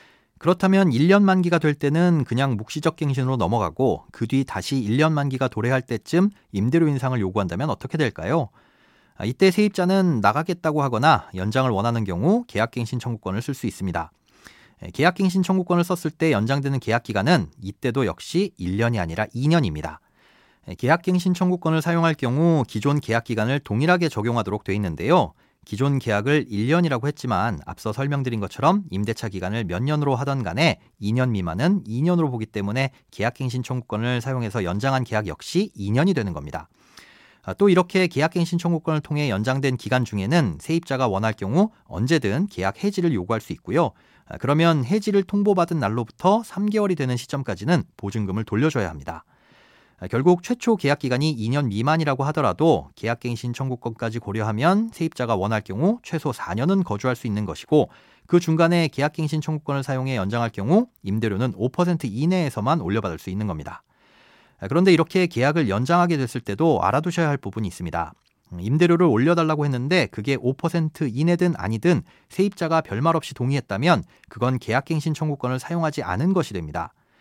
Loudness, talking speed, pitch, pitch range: -22 LUFS, 380 characters per minute, 135 Hz, 110-165 Hz